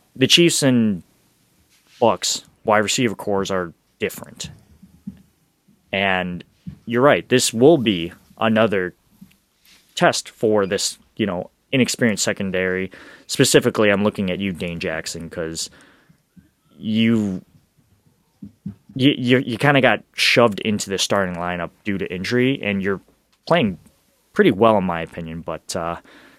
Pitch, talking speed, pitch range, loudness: 100 Hz, 125 wpm, 90-115 Hz, -19 LUFS